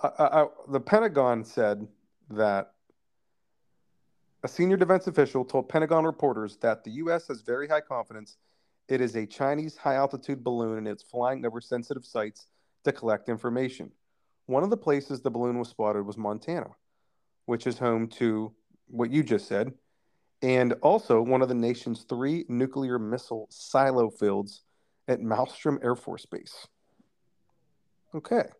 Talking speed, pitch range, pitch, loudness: 150 wpm, 110-140 Hz, 125 Hz, -28 LUFS